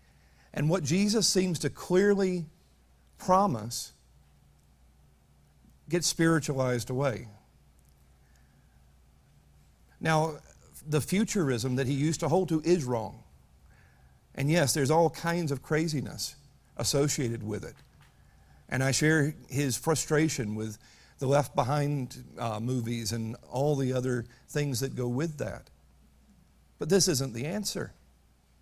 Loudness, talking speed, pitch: -29 LUFS, 115 wpm, 125 Hz